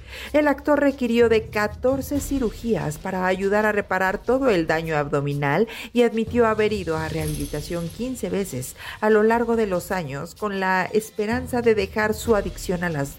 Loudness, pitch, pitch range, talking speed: -22 LUFS, 210 Hz, 175-230 Hz, 170 wpm